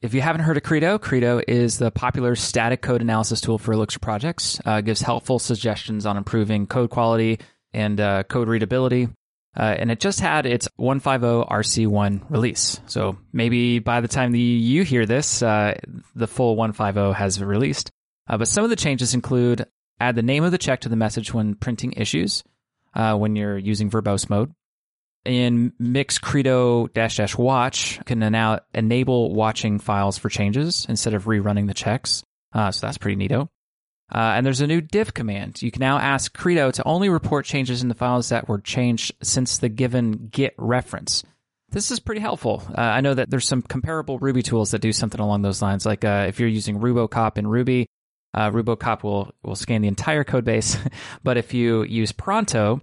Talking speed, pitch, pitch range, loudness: 195 wpm, 115 Hz, 110-125 Hz, -21 LUFS